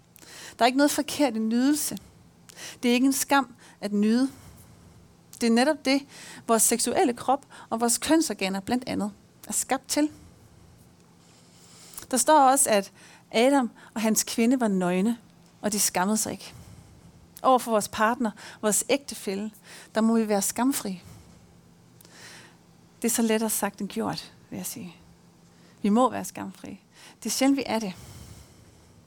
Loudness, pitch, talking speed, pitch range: -25 LUFS, 225 Hz, 155 wpm, 200-255 Hz